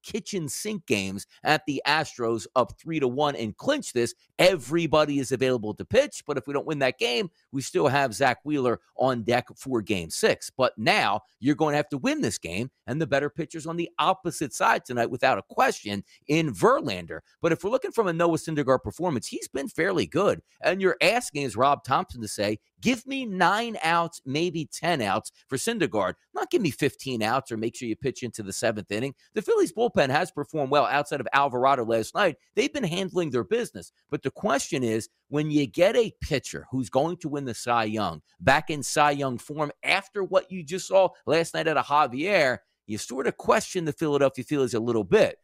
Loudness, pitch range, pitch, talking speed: -26 LUFS, 120-170 Hz, 145 Hz, 215 wpm